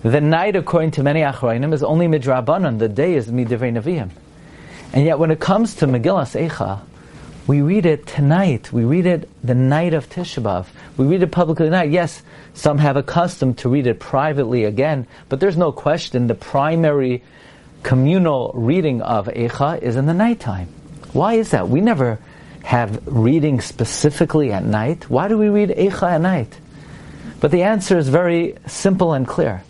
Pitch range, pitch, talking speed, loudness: 125-170 Hz, 150 Hz, 180 wpm, -17 LUFS